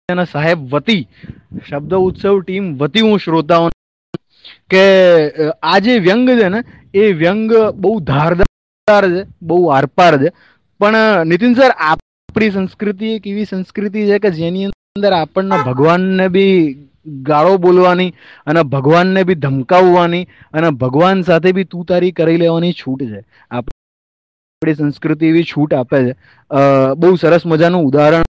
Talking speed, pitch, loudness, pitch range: 70 wpm, 175 Hz, -12 LUFS, 150-195 Hz